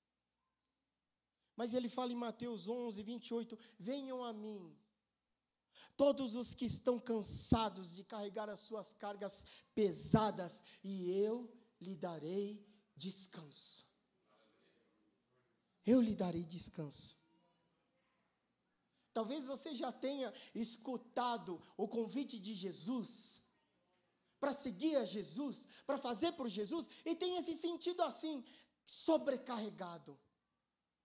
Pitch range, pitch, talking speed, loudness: 200-255 Hz, 230 Hz, 100 wpm, -41 LUFS